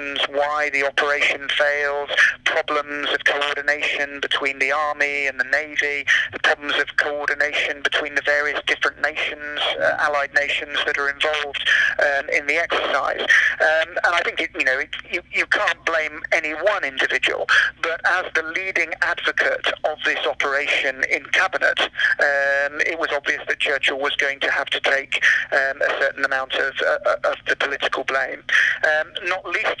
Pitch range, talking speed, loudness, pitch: 145-155 Hz, 165 wpm, -19 LUFS, 145 Hz